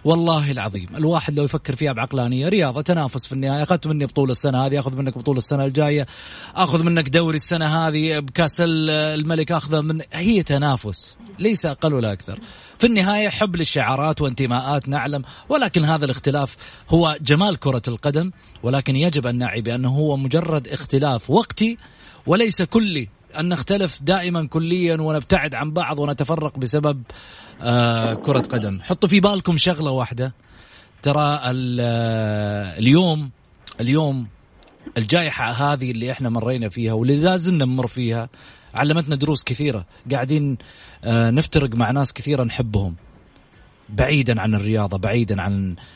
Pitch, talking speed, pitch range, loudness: 145 Hz, 135 wpm, 125-160 Hz, -20 LUFS